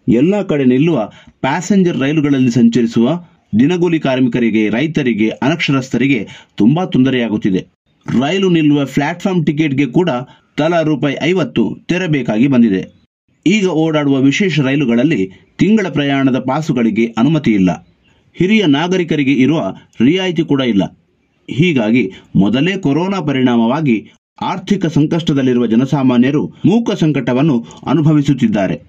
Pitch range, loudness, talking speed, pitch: 125-170 Hz, -14 LUFS, 100 wpm, 145 Hz